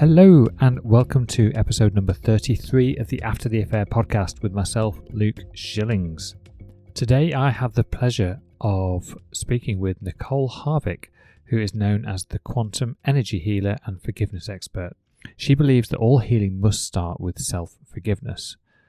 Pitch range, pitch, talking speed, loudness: 100-125 Hz, 110 Hz, 155 wpm, -21 LUFS